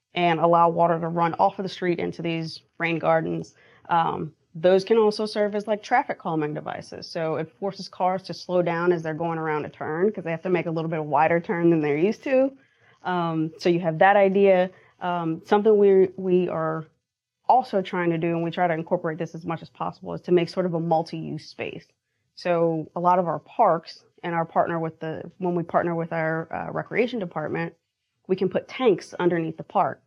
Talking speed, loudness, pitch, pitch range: 220 wpm, -24 LUFS, 170 Hz, 160-185 Hz